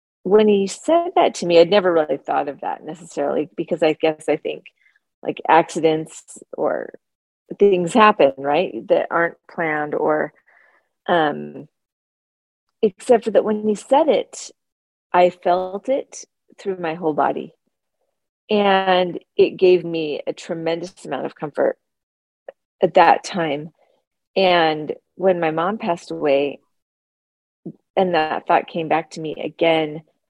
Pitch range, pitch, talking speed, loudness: 160-210 Hz, 175 Hz, 135 wpm, -19 LUFS